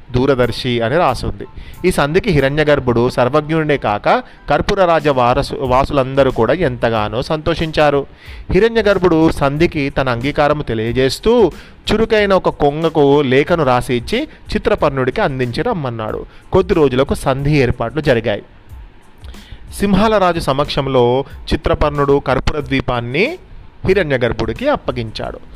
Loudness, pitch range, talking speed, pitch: -15 LUFS, 130-165 Hz, 105 wpm, 145 Hz